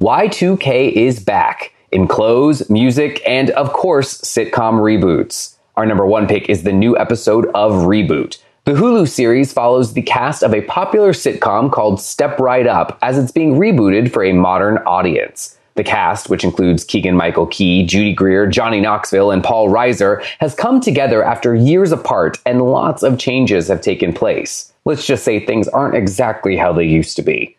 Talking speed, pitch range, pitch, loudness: 175 wpm, 95-130 Hz, 115 Hz, -13 LUFS